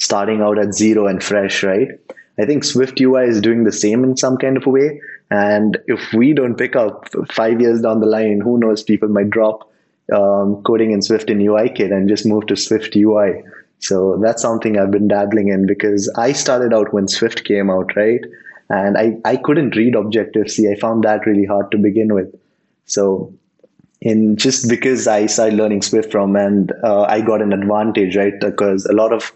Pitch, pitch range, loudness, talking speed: 105 Hz, 100-115 Hz, -15 LUFS, 205 wpm